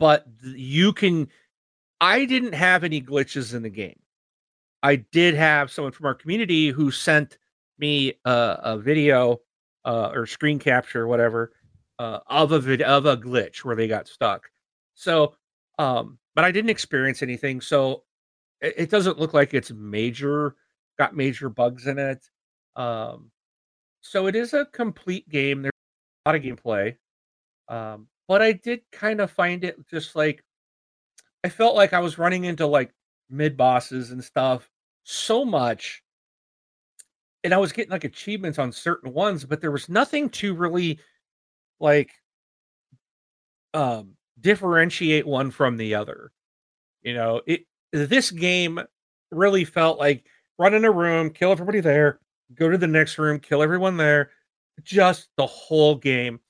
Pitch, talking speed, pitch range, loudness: 150 Hz, 155 wpm, 135-180 Hz, -22 LUFS